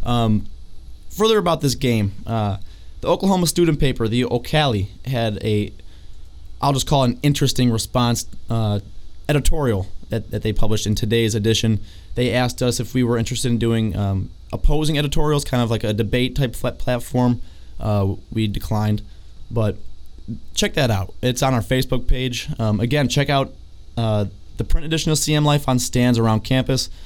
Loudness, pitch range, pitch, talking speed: -20 LUFS, 105-130 Hz, 115 Hz, 170 wpm